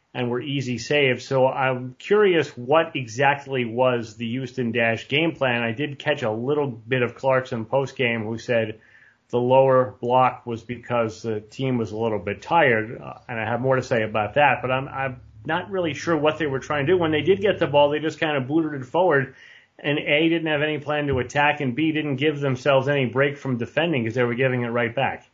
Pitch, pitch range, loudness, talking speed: 130 Hz, 120-150 Hz, -22 LUFS, 230 wpm